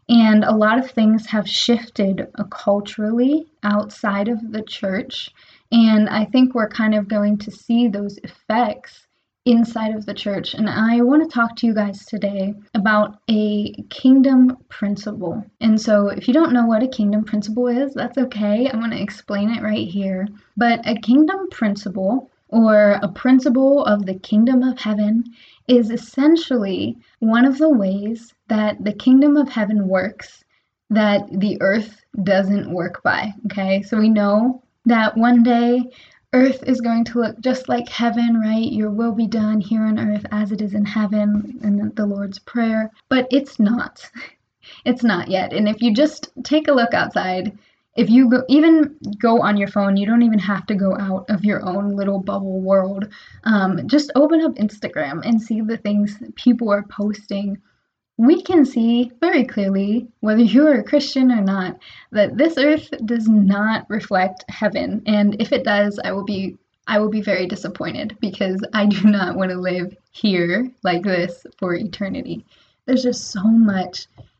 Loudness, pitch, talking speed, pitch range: -18 LUFS, 215 Hz, 175 wpm, 205-240 Hz